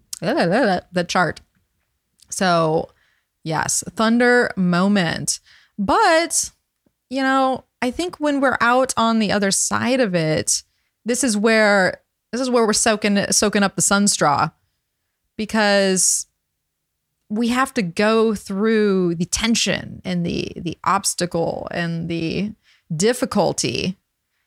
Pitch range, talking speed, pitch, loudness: 175-230 Hz, 115 wpm, 205 Hz, -19 LUFS